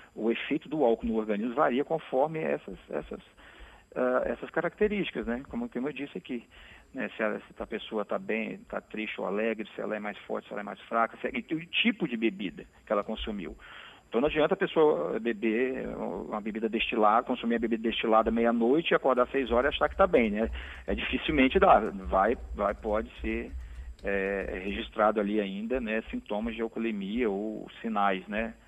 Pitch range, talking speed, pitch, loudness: 105-125 Hz, 195 wpm, 115 Hz, -29 LUFS